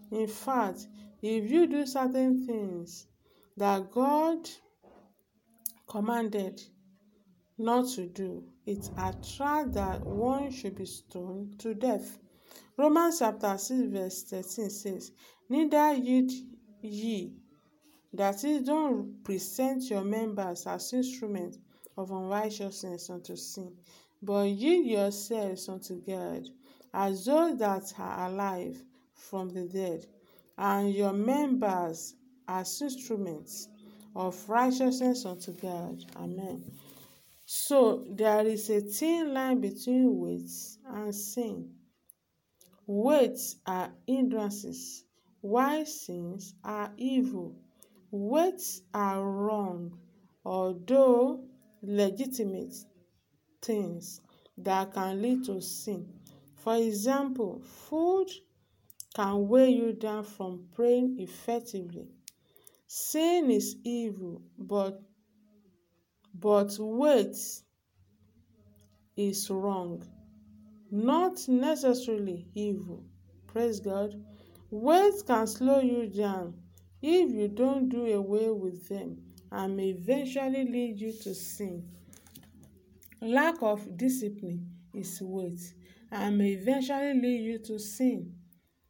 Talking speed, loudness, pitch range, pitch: 95 wpm, -30 LUFS, 185-250 Hz, 210 Hz